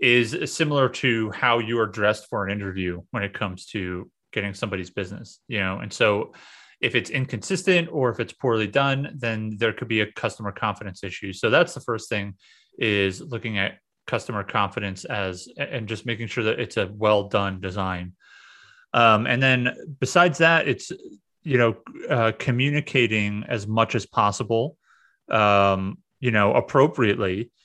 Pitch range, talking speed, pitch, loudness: 100-125 Hz, 165 wpm, 110 Hz, -23 LUFS